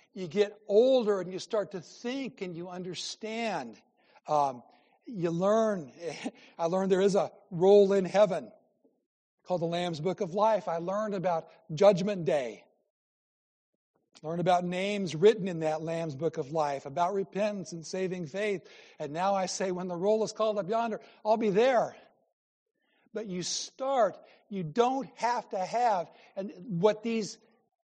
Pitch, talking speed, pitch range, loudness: 195 Hz, 155 wpm, 175-220 Hz, -30 LUFS